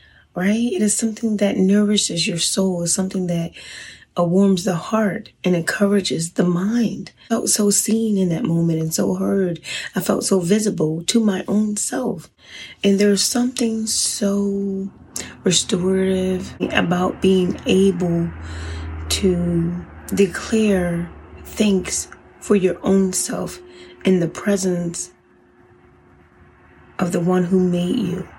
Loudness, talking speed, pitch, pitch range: -19 LUFS, 125 wpm, 190 Hz, 175-205 Hz